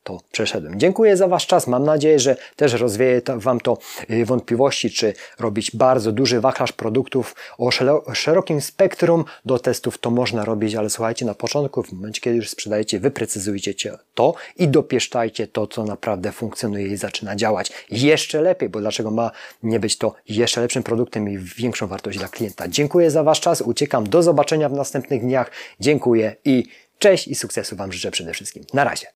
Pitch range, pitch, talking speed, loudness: 110-140 Hz, 120 Hz, 175 wpm, -20 LUFS